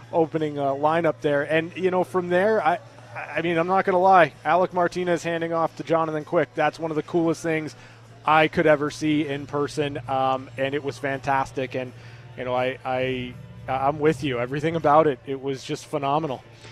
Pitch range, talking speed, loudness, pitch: 130-160 Hz, 195 wpm, -23 LUFS, 150 Hz